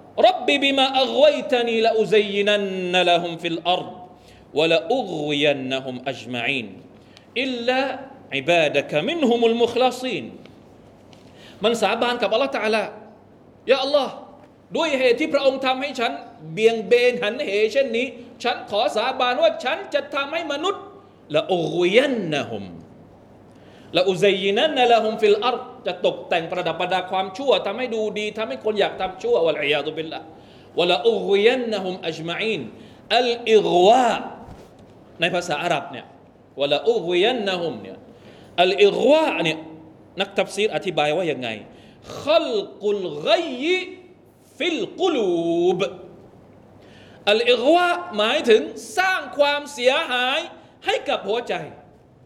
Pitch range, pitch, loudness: 185-280 Hz, 235 Hz, -21 LUFS